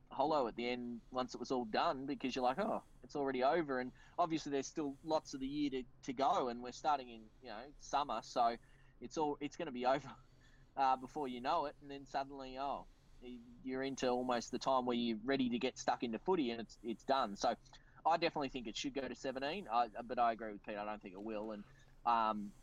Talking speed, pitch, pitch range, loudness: 240 wpm, 130 Hz, 120-140 Hz, -39 LUFS